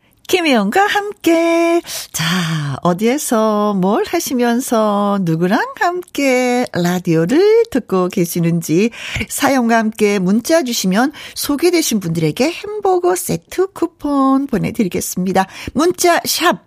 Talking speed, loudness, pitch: 240 characters per minute, -15 LUFS, 245 Hz